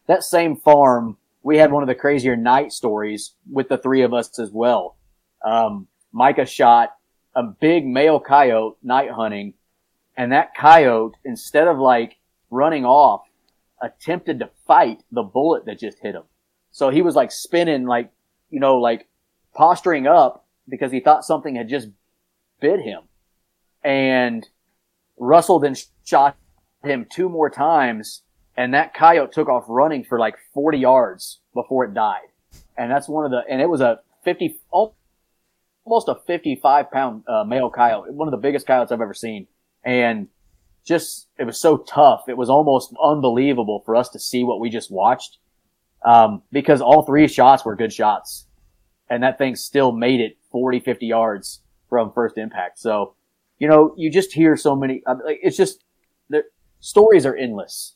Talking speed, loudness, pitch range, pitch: 170 wpm, -17 LUFS, 115-155 Hz, 130 Hz